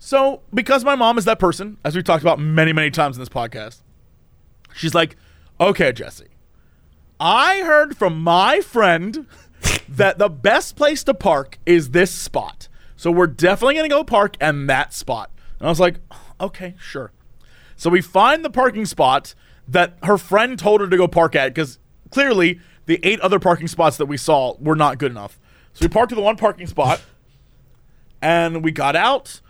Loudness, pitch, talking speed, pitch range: -17 LUFS, 175 Hz, 185 wpm, 150-210 Hz